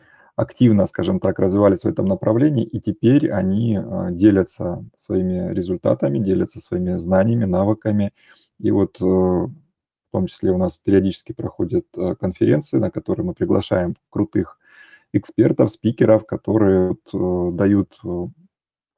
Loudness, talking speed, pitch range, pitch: -19 LUFS, 115 wpm, 95-110 Hz, 95 Hz